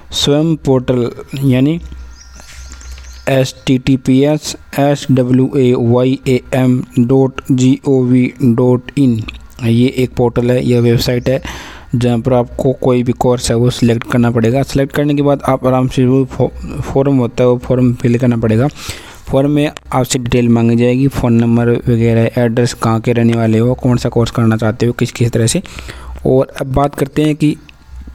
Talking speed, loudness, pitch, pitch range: 175 wpm, -13 LUFS, 125 Hz, 120-135 Hz